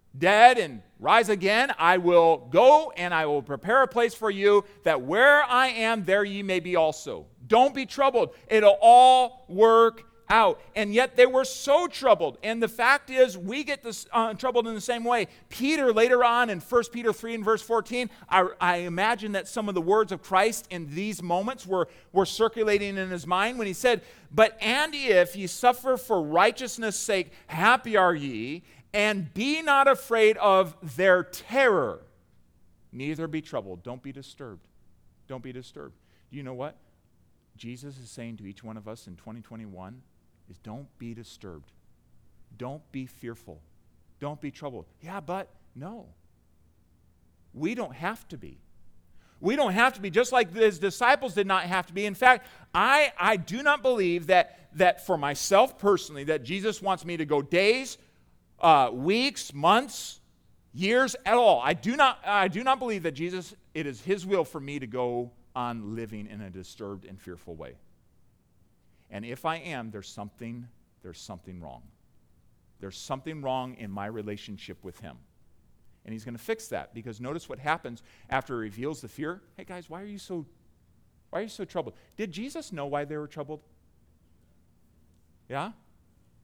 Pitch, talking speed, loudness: 180 Hz, 180 wpm, -24 LUFS